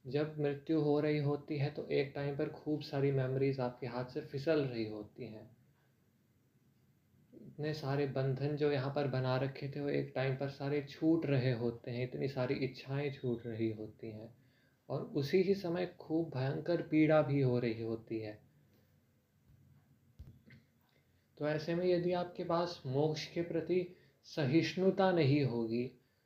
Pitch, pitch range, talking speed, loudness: 140 Hz, 125-155 Hz, 160 wpm, -36 LUFS